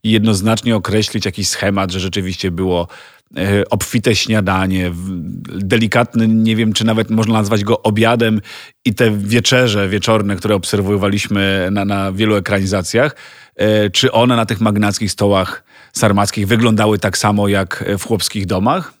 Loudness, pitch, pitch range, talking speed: -15 LUFS, 105 Hz, 100-110 Hz, 135 wpm